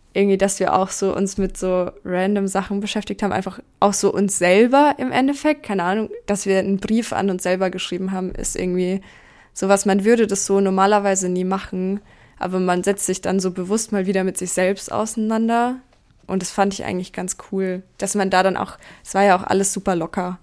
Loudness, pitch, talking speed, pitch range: -20 LUFS, 195 Hz, 210 wpm, 185-205 Hz